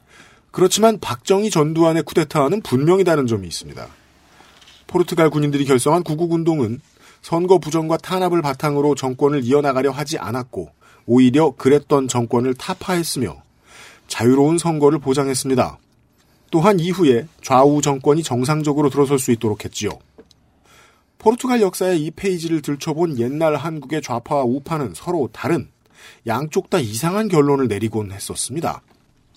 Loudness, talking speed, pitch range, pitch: -18 LUFS, 340 characters per minute, 130-170 Hz, 145 Hz